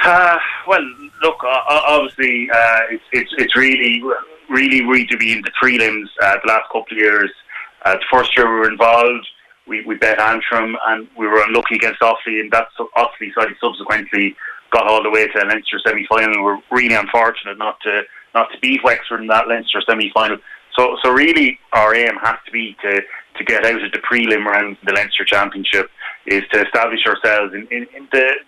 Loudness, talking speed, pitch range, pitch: -15 LUFS, 210 wpm, 110-125 Hz, 115 Hz